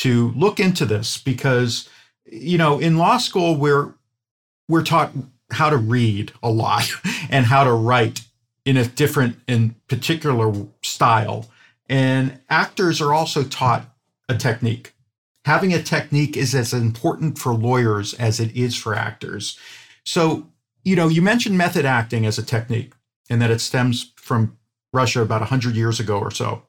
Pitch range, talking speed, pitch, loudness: 115-150 Hz, 155 wpm, 125 Hz, -19 LUFS